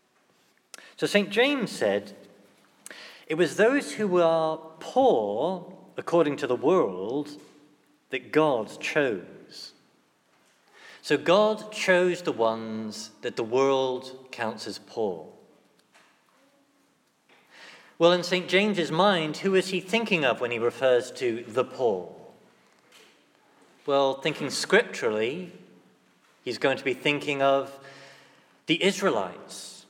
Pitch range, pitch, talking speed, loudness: 130-185 Hz, 155 Hz, 110 wpm, -26 LUFS